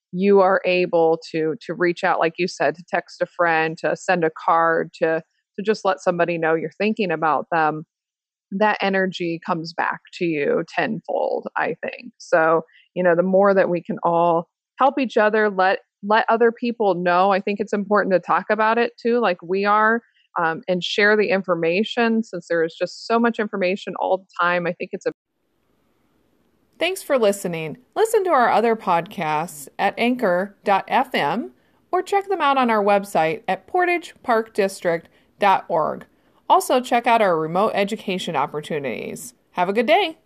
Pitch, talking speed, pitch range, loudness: 190 Hz, 170 wpm, 170-220 Hz, -20 LUFS